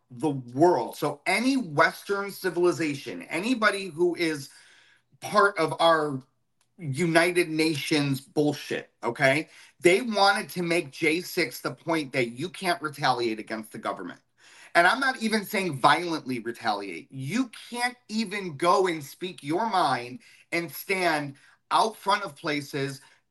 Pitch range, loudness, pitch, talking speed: 140-195 Hz, -26 LUFS, 165 Hz, 130 wpm